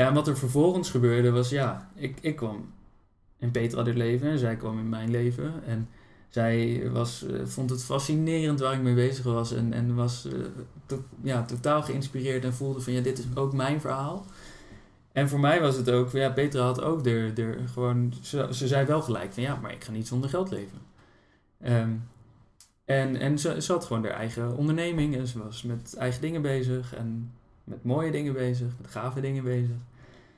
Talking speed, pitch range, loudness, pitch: 200 wpm, 120-135 Hz, -28 LUFS, 125 Hz